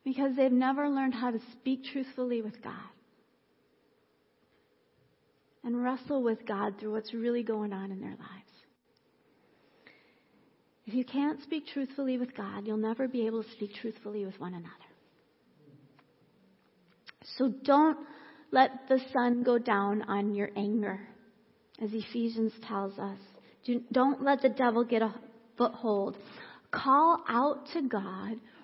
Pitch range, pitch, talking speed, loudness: 215-265 Hz, 240 Hz, 135 wpm, -31 LUFS